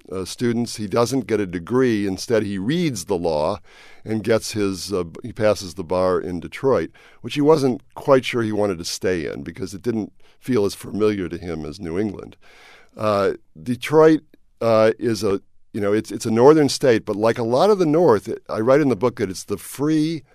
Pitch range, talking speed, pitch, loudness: 100-125 Hz, 210 wpm, 110 Hz, -20 LUFS